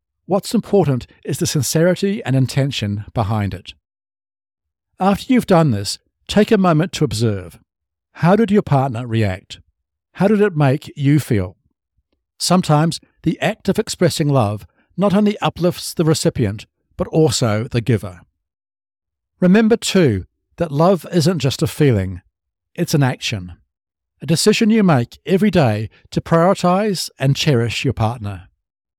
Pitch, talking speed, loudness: 135 Hz, 140 wpm, -17 LUFS